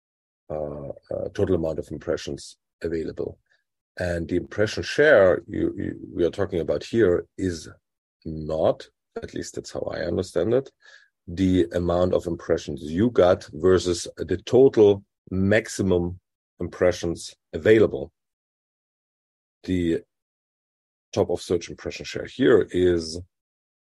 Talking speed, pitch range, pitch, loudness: 115 wpm, 85-95 Hz, 90 Hz, -23 LUFS